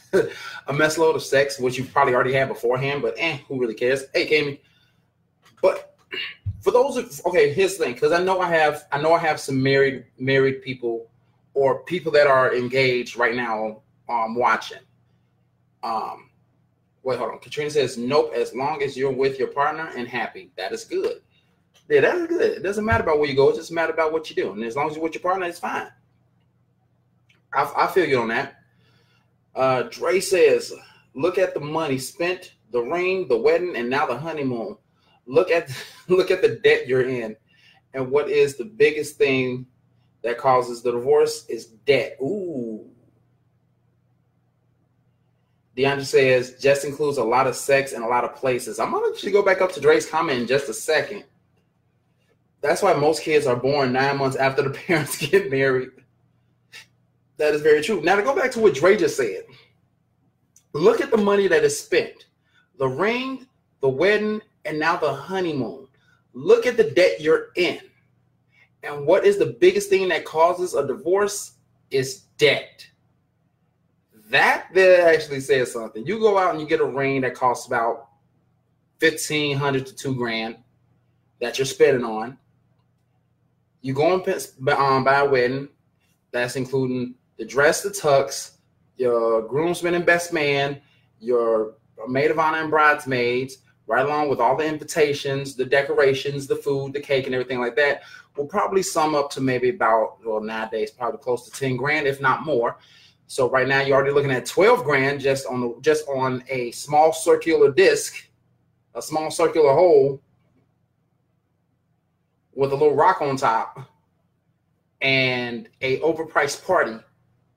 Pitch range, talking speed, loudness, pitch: 130-190 Hz, 170 wpm, -21 LUFS, 145 Hz